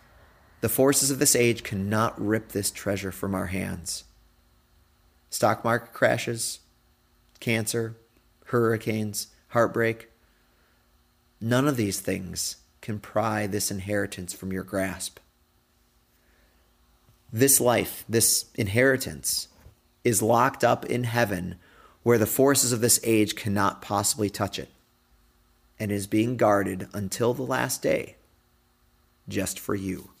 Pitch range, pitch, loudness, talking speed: 95-115 Hz, 105 Hz, -25 LUFS, 115 wpm